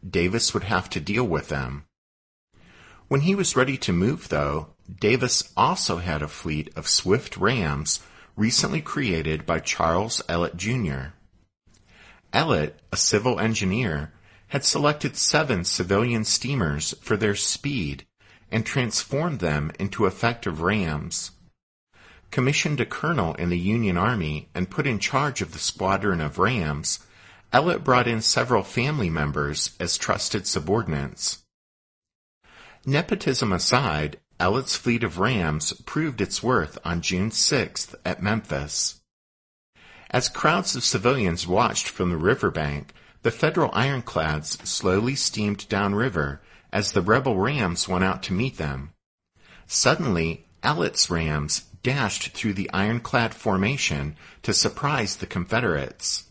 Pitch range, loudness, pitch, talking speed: 75-115 Hz, -23 LUFS, 95 Hz, 130 wpm